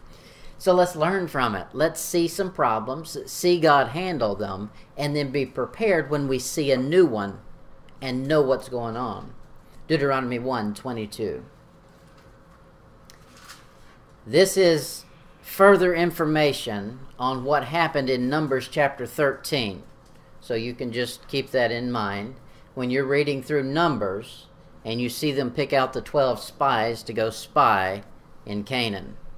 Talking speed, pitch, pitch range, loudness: 140 wpm, 135 Hz, 120-155 Hz, -24 LUFS